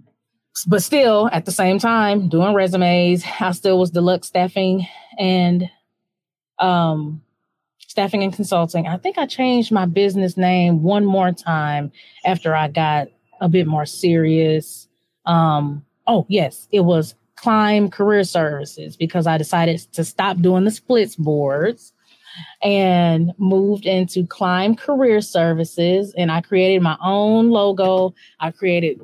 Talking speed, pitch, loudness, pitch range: 135 wpm, 180 Hz, -18 LUFS, 165-200 Hz